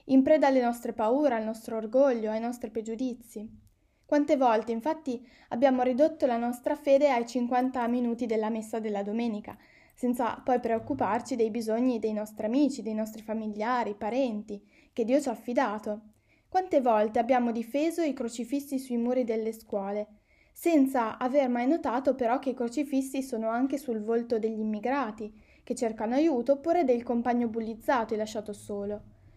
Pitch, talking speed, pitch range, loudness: 240 Hz, 155 wpm, 220-265 Hz, -29 LUFS